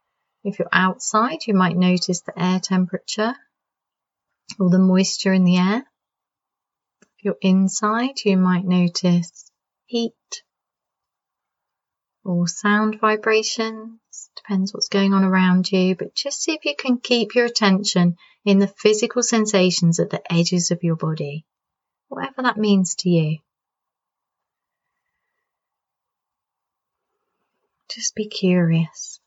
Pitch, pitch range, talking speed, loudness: 195 Hz, 180-220 Hz, 120 wpm, -19 LUFS